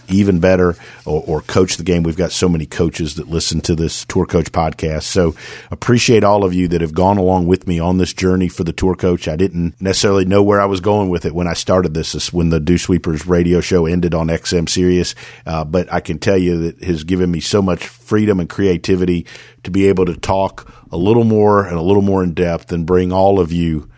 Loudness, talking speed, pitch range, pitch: -15 LUFS, 240 wpm, 85-95 Hz, 90 Hz